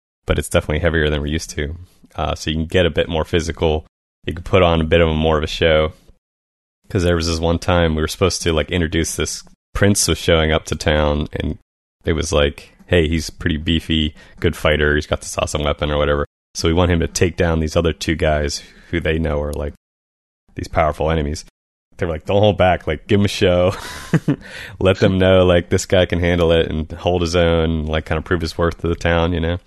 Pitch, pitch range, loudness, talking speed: 80 Hz, 75-90 Hz, -18 LUFS, 245 wpm